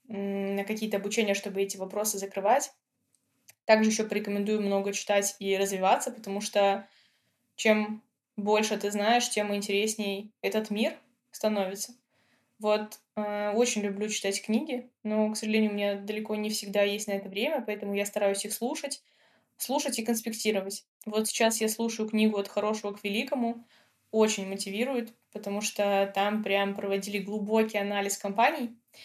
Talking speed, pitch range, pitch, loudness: 145 wpm, 200-220 Hz, 210 Hz, -29 LUFS